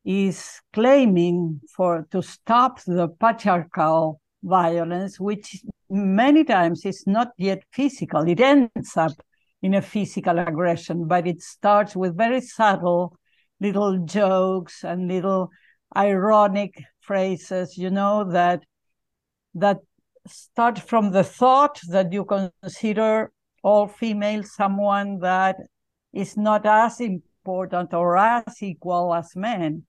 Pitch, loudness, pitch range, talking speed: 195 Hz, -21 LUFS, 175-210 Hz, 115 wpm